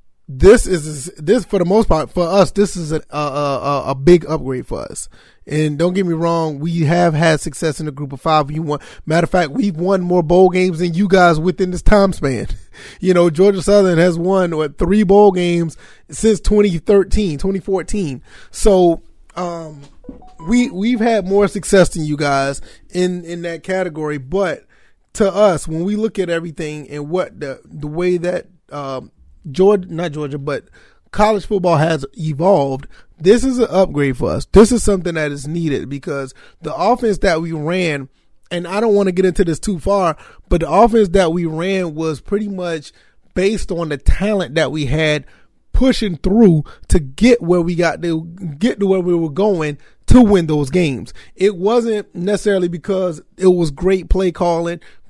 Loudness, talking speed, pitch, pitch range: -16 LUFS, 185 wpm, 175 Hz, 155-195 Hz